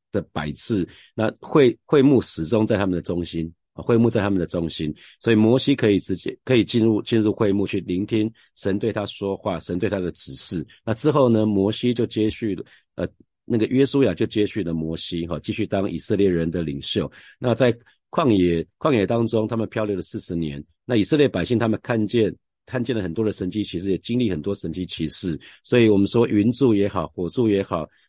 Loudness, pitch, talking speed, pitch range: -22 LUFS, 105 Hz, 310 characters per minute, 85-115 Hz